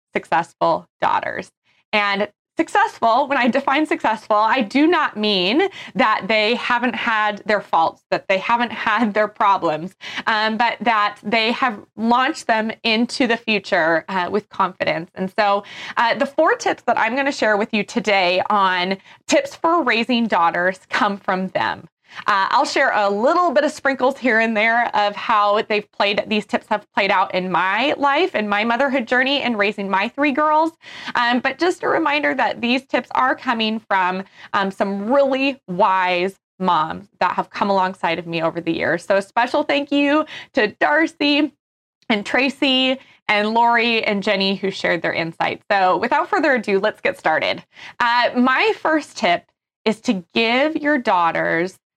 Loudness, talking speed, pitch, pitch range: -19 LUFS, 170 wpm, 230 Hz, 205-275 Hz